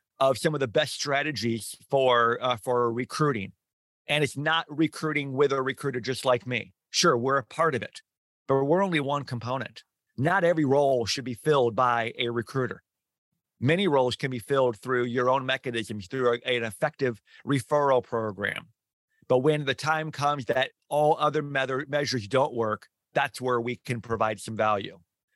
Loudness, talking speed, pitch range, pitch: -26 LUFS, 175 wpm, 120-145 Hz, 130 Hz